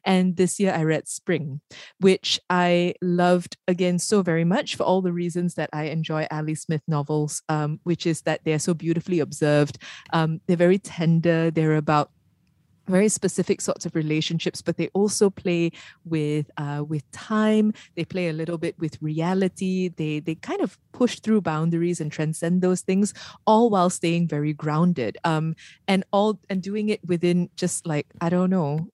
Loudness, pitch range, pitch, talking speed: -24 LUFS, 155-185 Hz, 170 Hz, 175 wpm